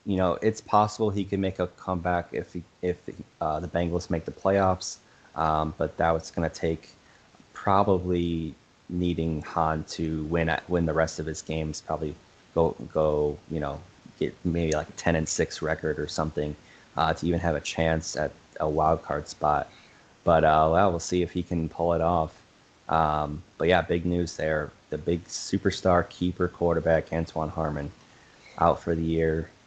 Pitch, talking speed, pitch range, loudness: 80 Hz, 180 wpm, 80-90 Hz, -27 LUFS